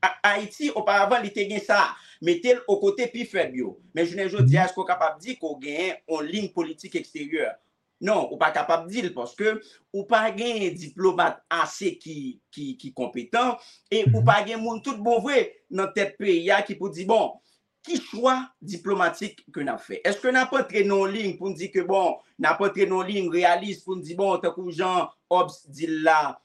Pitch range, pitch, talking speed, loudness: 170-220 Hz, 195 Hz, 210 wpm, -24 LUFS